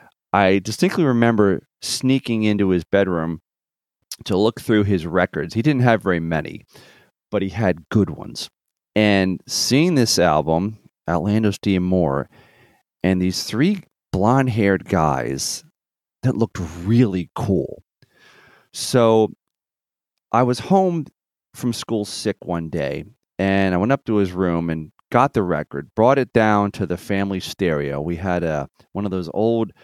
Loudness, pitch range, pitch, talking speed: -20 LUFS, 90-115 Hz, 100 Hz, 145 wpm